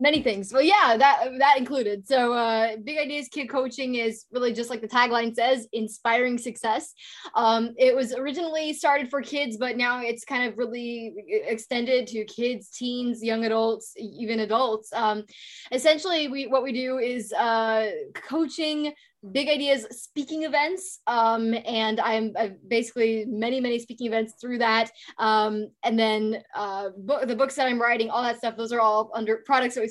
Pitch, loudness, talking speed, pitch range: 240 Hz, -25 LUFS, 175 wpm, 225-270 Hz